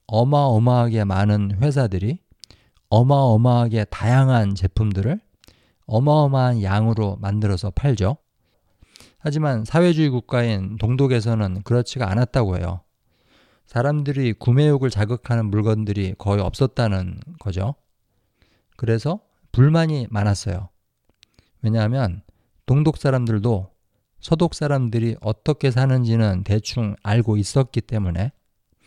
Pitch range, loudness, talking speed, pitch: 105-130 Hz, -20 LUFS, 270 characters per minute, 115 Hz